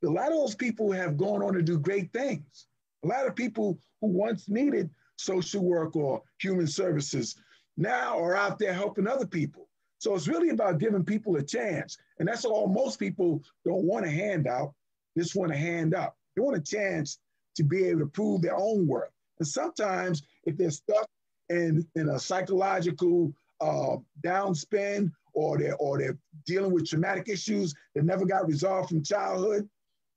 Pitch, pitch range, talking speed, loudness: 185 Hz, 165-205 Hz, 180 wpm, -29 LUFS